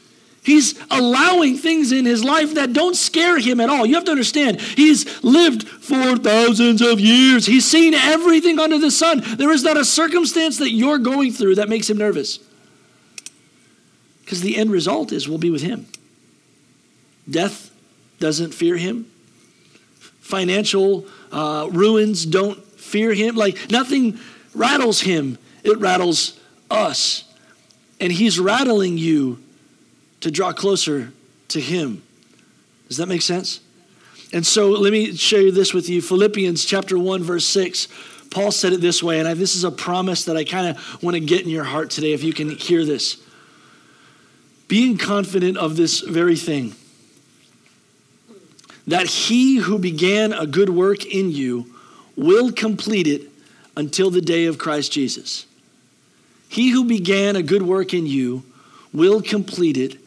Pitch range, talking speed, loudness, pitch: 170-240 Hz, 155 wpm, -17 LUFS, 195 Hz